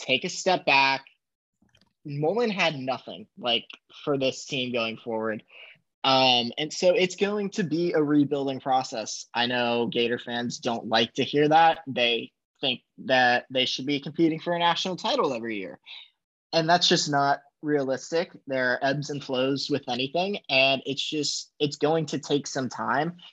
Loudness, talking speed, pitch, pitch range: -25 LUFS, 170 wpm, 140 Hz, 130-165 Hz